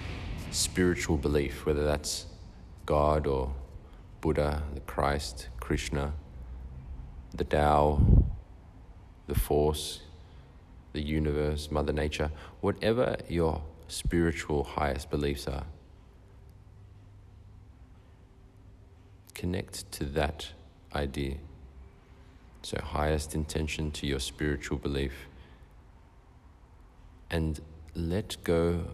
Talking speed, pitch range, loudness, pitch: 80 wpm, 75-90 Hz, -31 LUFS, 80 Hz